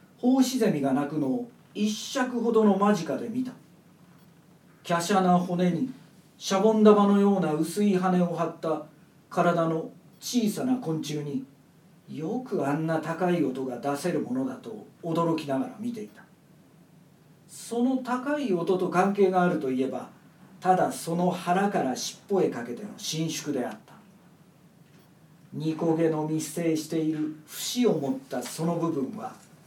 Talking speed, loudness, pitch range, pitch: 255 characters per minute, -27 LUFS, 160-205 Hz, 175 Hz